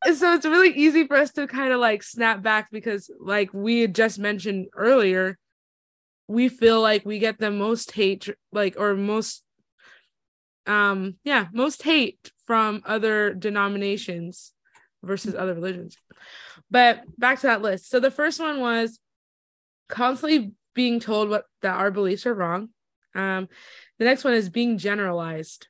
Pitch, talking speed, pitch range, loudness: 215 Hz, 155 wpm, 200-245 Hz, -22 LUFS